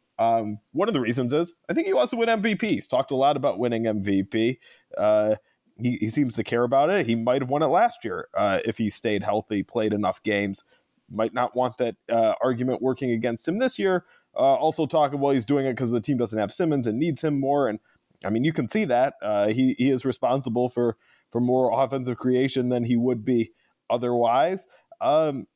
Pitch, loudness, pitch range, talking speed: 125 Hz, -24 LUFS, 115-140 Hz, 220 wpm